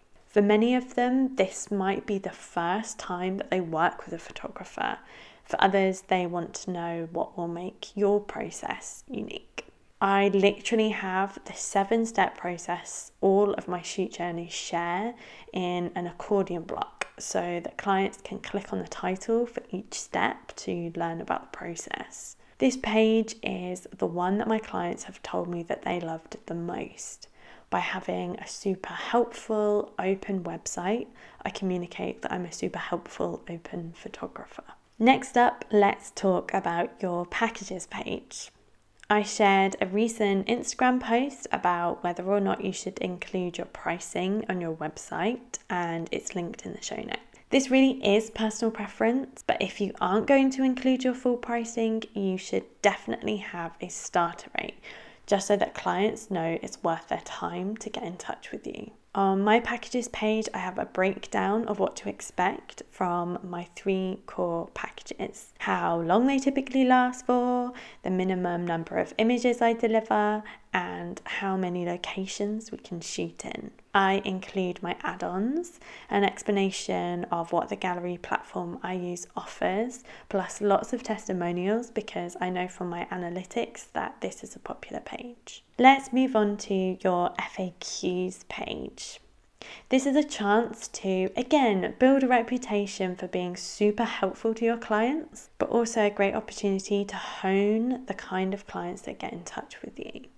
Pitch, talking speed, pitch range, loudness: 200 Hz, 165 wpm, 180-225 Hz, -28 LUFS